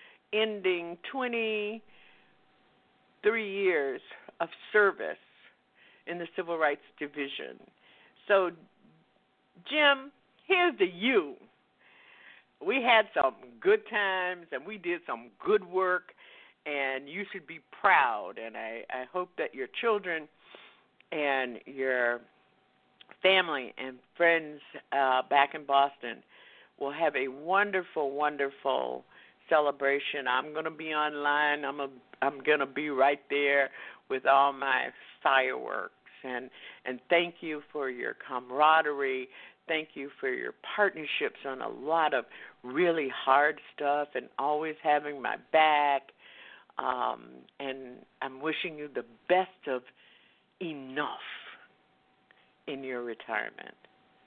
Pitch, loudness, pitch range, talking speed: 150 Hz, -29 LUFS, 140-190 Hz, 115 wpm